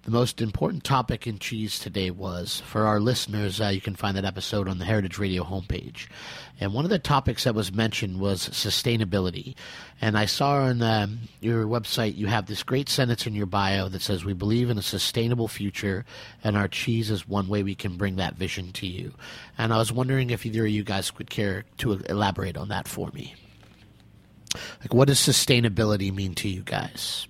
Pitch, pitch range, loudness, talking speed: 105 Hz, 100-115 Hz, -26 LUFS, 205 wpm